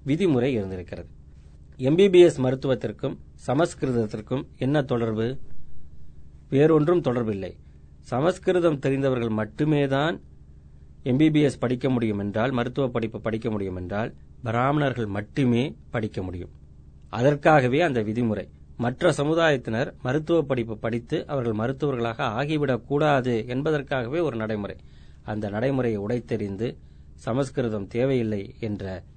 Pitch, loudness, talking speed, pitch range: 120 Hz, -24 LUFS, 95 wpm, 100-140 Hz